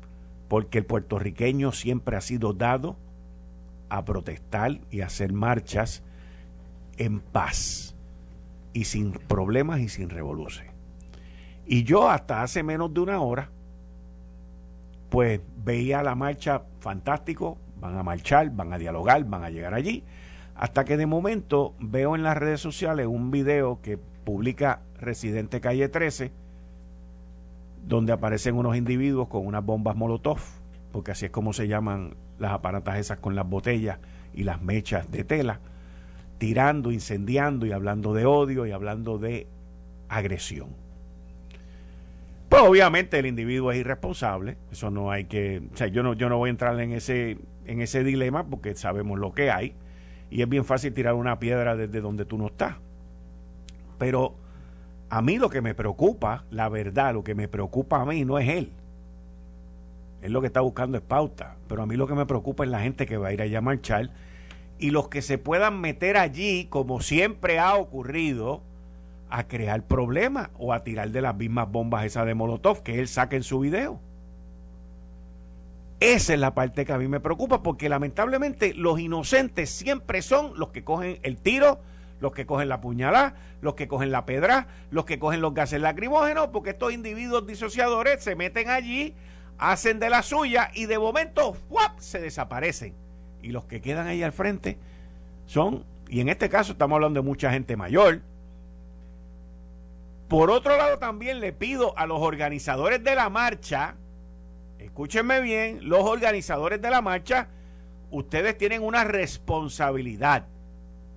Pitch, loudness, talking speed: 115 Hz, -26 LUFS, 165 wpm